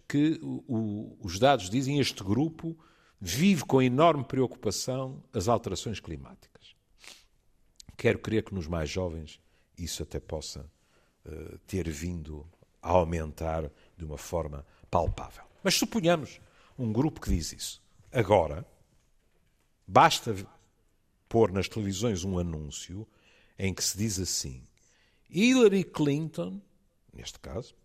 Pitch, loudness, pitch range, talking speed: 105 Hz, -29 LUFS, 85-130 Hz, 120 wpm